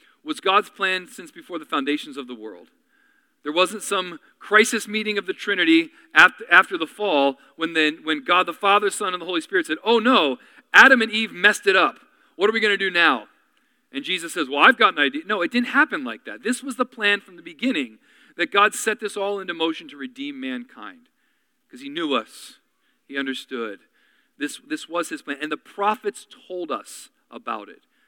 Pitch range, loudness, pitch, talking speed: 180-275 Hz, -20 LUFS, 215 Hz, 205 wpm